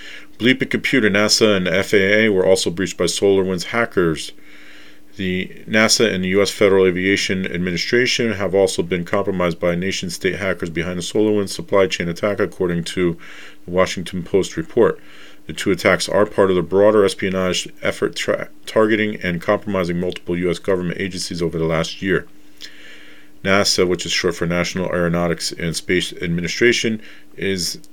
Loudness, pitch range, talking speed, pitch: -18 LUFS, 85-105 Hz, 155 wpm, 95 Hz